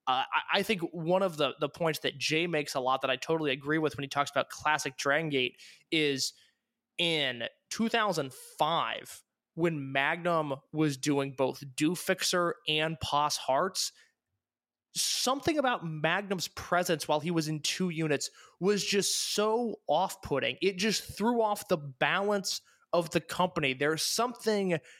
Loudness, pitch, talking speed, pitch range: -30 LUFS, 160 Hz, 155 wpm, 145-195 Hz